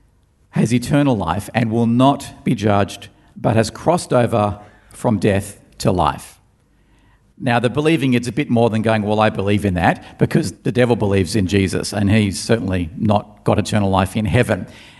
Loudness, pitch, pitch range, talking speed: -18 LUFS, 110 Hz, 100-125 Hz, 180 wpm